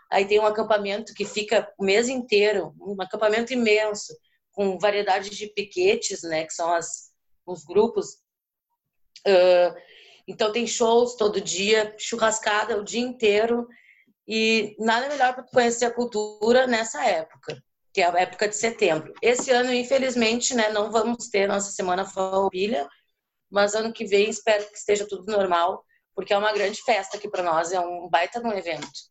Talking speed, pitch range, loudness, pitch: 165 wpm, 195-230 Hz, -23 LUFS, 210 Hz